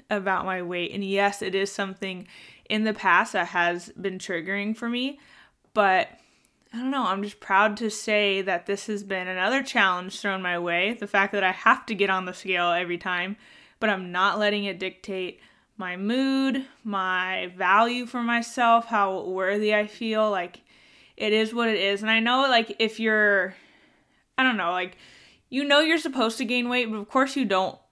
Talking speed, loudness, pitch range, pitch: 195 wpm, -24 LUFS, 190-230 Hz, 205 Hz